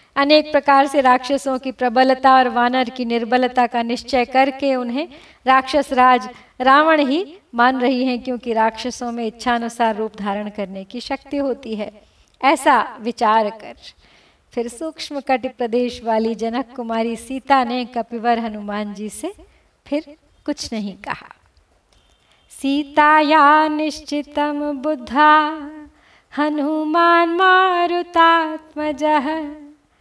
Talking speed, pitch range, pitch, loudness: 115 wpm, 240-300 Hz, 265 Hz, -18 LUFS